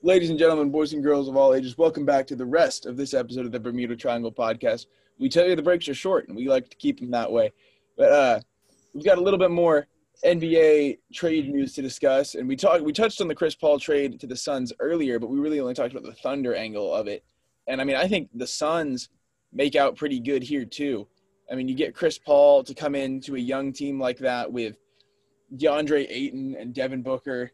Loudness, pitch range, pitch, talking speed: -24 LUFS, 130-170 Hz, 145 Hz, 235 wpm